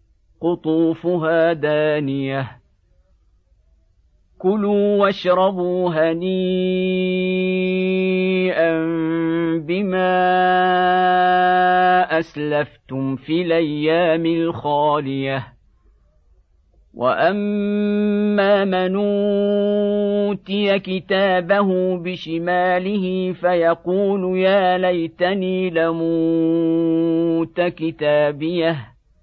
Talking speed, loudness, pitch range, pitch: 40 wpm, -19 LUFS, 155-185 Hz, 175 Hz